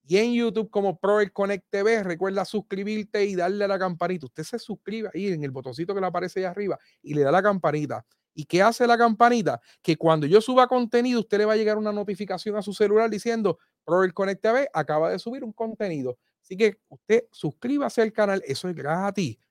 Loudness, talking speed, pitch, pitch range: -24 LUFS, 220 wpm, 200 Hz, 180-220 Hz